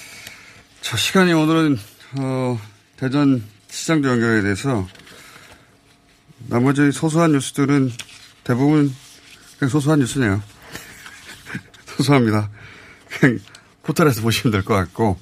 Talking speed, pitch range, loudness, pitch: 230 characters per minute, 105-145 Hz, -19 LUFS, 130 Hz